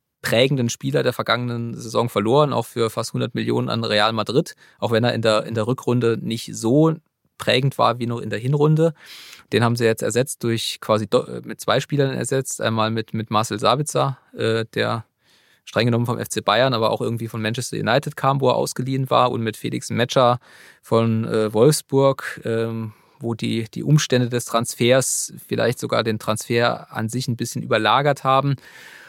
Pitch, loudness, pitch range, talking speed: 120 Hz, -21 LUFS, 115-135 Hz, 180 wpm